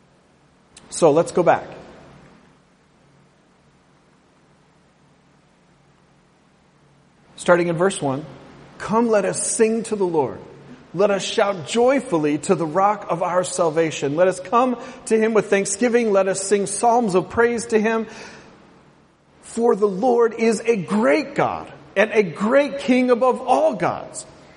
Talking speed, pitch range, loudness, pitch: 130 wpm, 175-230 Hz, -19 LUFS, 200 Hz